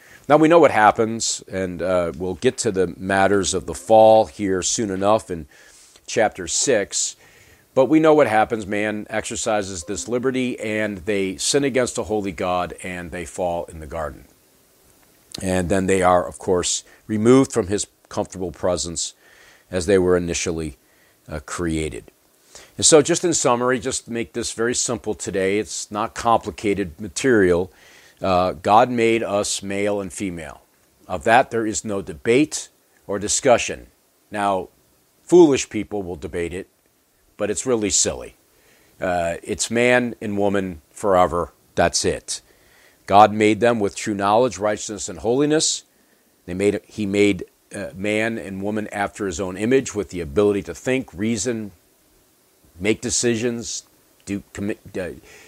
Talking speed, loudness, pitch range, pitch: 150 wpm, -20 LUFS, 95-115 Hz, 105 Hz